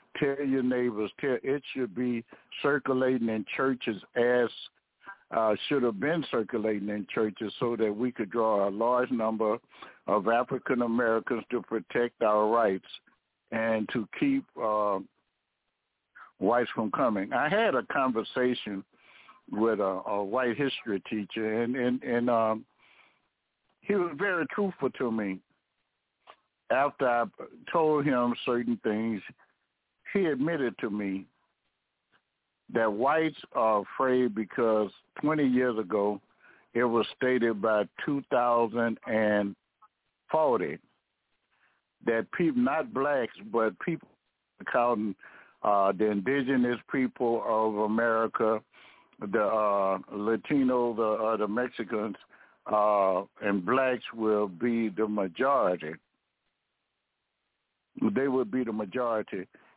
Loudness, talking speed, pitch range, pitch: -29 LUFS, 115 wpm, 105-125 Hz, 115 Hz